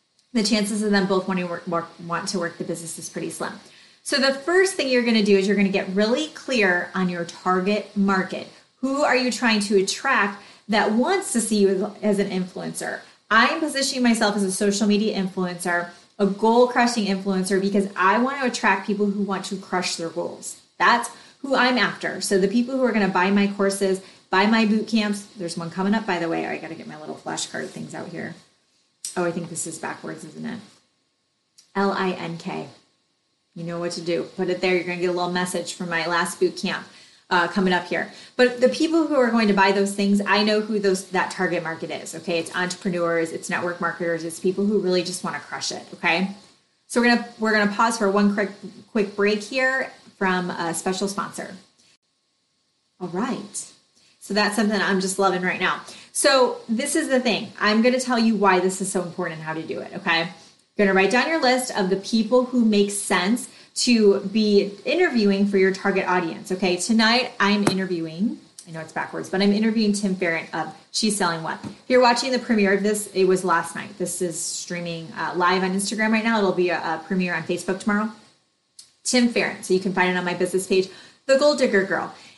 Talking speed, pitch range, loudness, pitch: 220 wpm, 180-220 Hz, -22 LUFS, 195 Hz